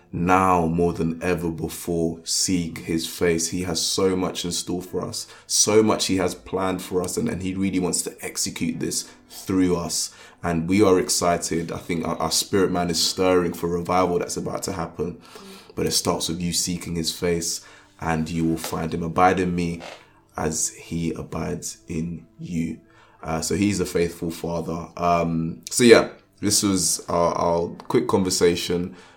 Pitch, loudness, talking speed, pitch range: 85 Hz, -23 LUFS, 180 wpm, 80-90 Hz